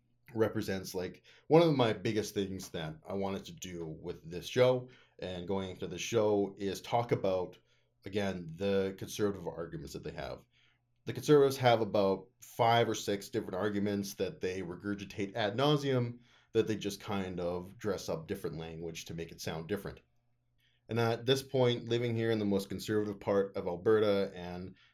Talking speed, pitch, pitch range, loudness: 175 wpm, 105 Hz, 95-120 Hz, -33 LUFS